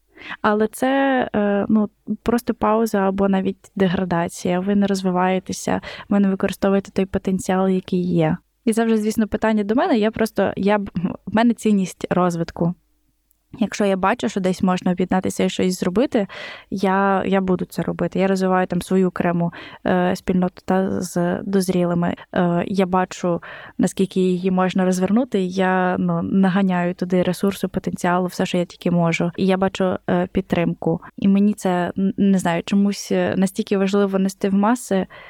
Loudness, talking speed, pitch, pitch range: -20 LUFS, 150 wpm, 190 Hz, 180-205 Hz